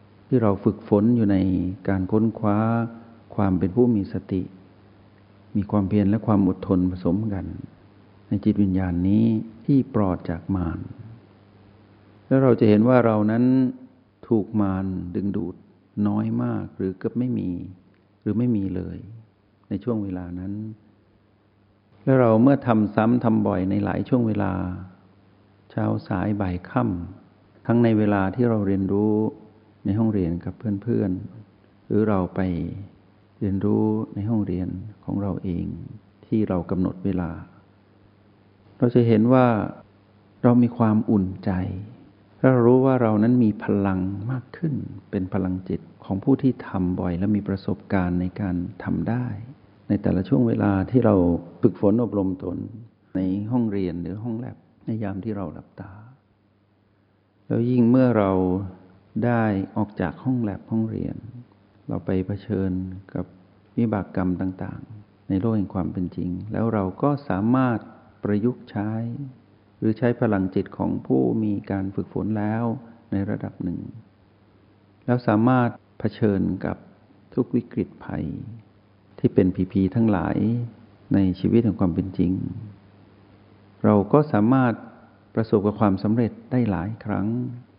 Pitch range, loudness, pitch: 95-115 Hz, -23 LUFS, 105 Hz